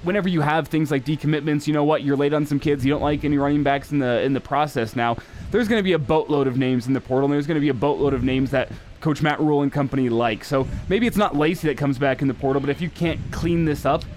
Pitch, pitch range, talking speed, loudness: 145 Hz, 135-155 Hz, 290 wpm, -21 LUFS